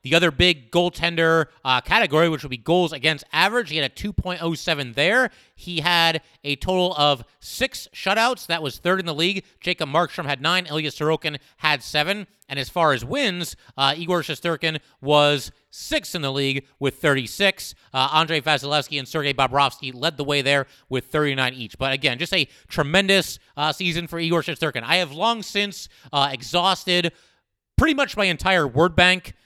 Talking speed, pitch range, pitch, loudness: 180 wpm, 140-180 Hz, 160 Hz, -21 LUFS